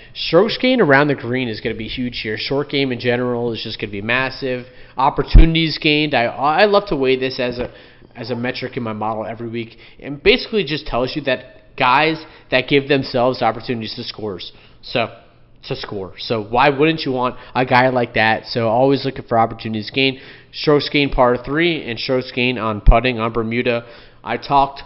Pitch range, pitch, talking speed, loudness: 115-135 Hz, 125 Hz, 200 wpm, -18 LUFS